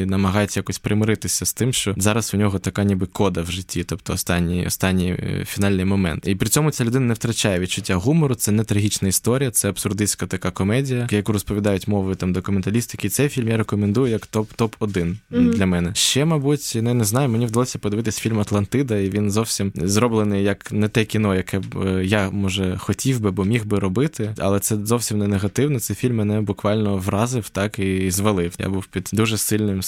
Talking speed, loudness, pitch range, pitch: 190 wpm, -21 LUFS, 95-115 Hz, 105 Hz